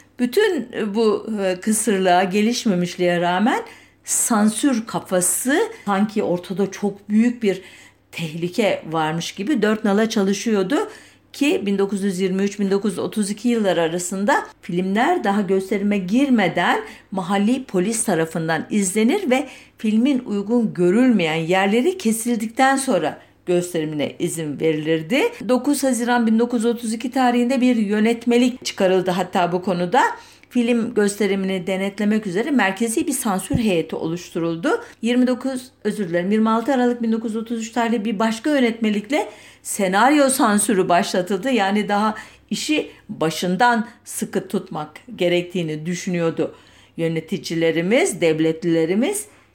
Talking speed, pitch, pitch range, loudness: 100 wpm, 210 Hz, 185-240 Hz, -20 LUFS